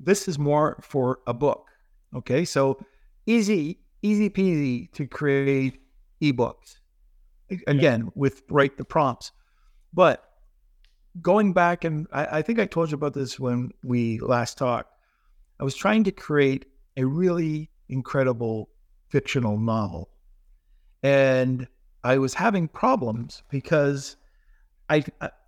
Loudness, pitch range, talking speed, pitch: -24 LUFS, 125-155 Hz, 125 wpm, 135 Hz